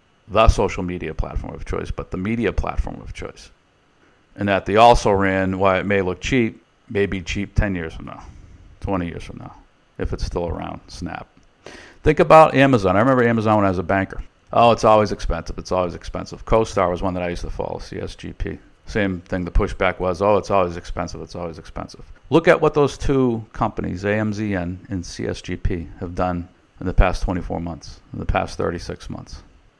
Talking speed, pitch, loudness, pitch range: 195 wpm, 95 Hz, -20 LUFS, 90-105 Hz